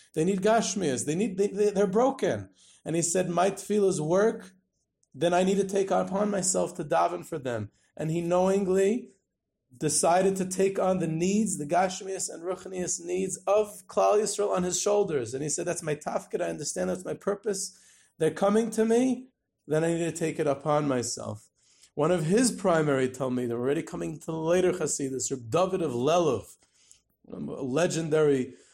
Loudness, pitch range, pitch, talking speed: -27 LUFS, 150-195 Hz, 180 Hz, 185 wpm